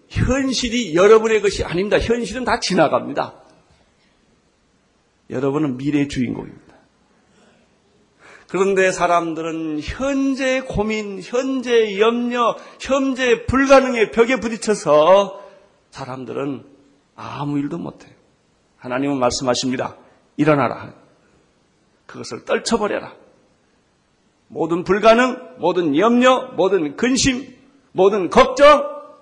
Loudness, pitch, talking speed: -18 LUFS, 210 Hz, 235 characters per minute